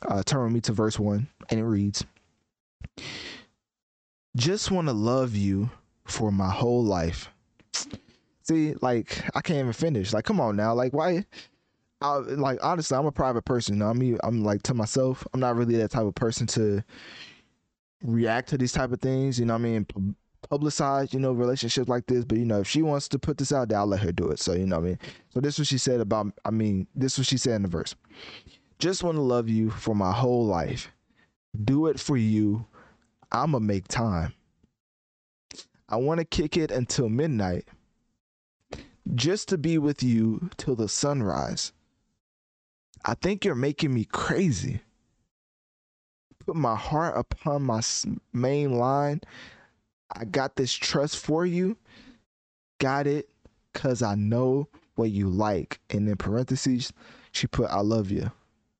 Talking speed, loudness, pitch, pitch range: 180 wpm, -27 LUFS, 120 Hz, 105-140 Hz